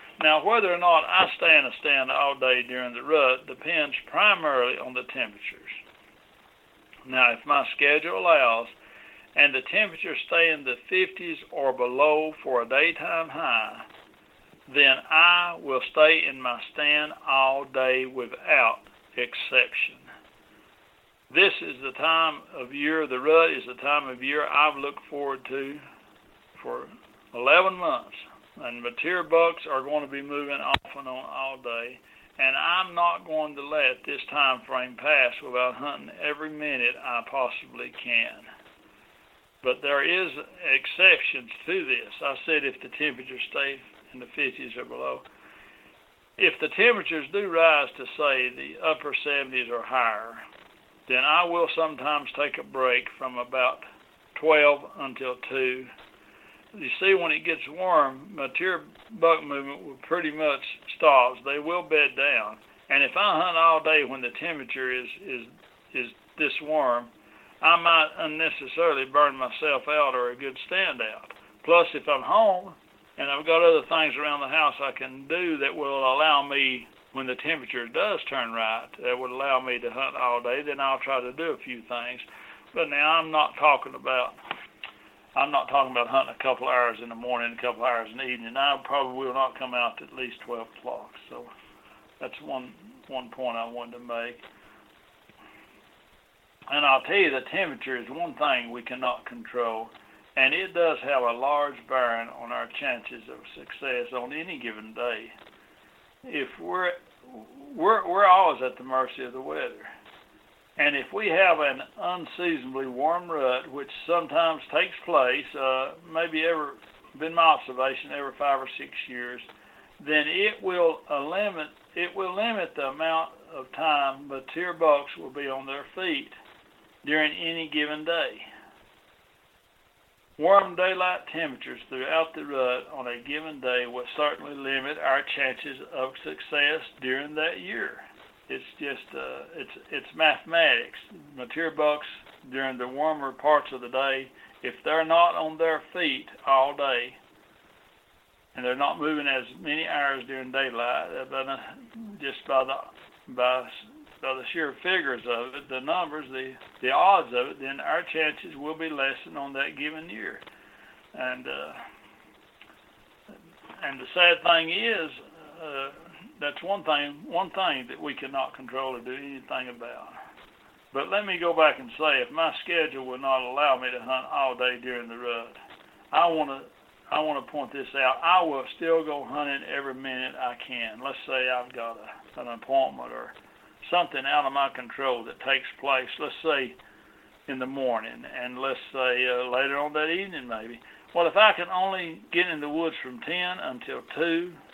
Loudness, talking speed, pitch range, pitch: -25 LUFS, 165 wpm, 130-160 Hz, 140 Hz